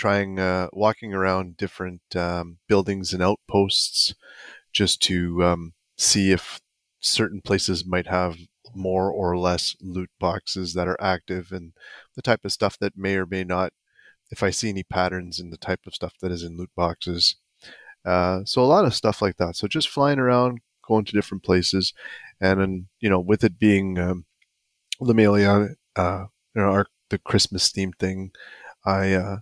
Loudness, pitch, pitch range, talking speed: -23 LUFS, 95 Hz, 90-100 Hz, 175 wpm